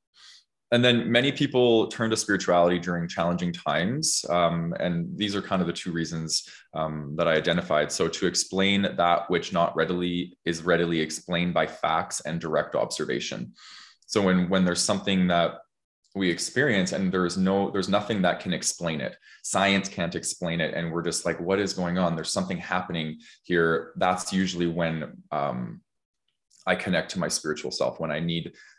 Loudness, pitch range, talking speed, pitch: -26 LUFS, 85-95 Hz, 175 wpm, 85 Hz